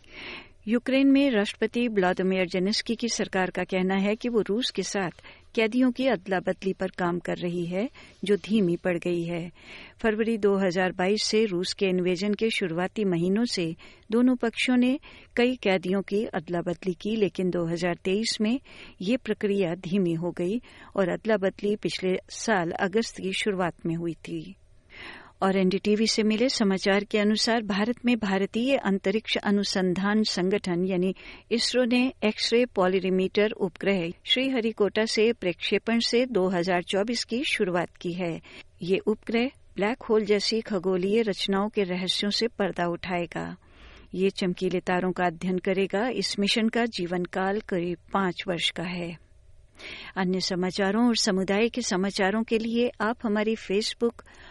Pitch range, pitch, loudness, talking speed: 185-220 Hz, 195 Hz, -26 LUFS, 150 wpm